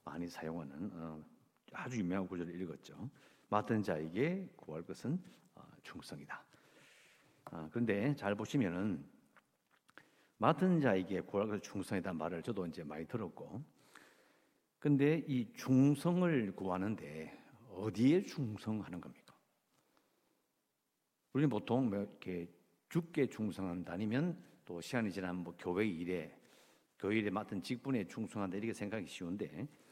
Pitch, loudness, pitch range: 105 Hz, -38 LUFS, 90-130 Hz